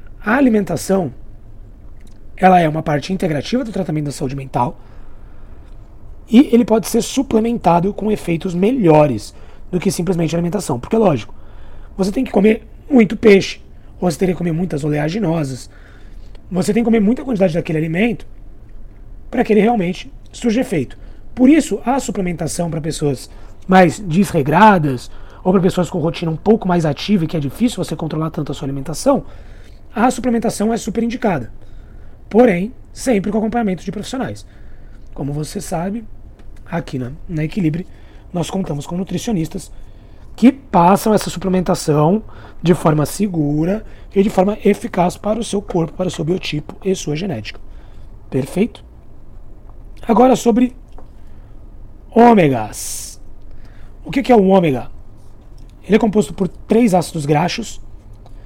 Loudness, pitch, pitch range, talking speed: -16 LUFS, 175 Hz, 145-210 Hz, 145 wpm